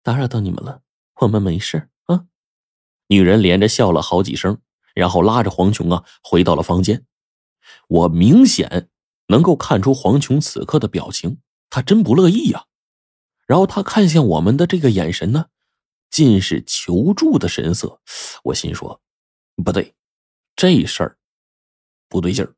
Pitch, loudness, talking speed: 115 Hz, -16 LUFS, 225 characters per minute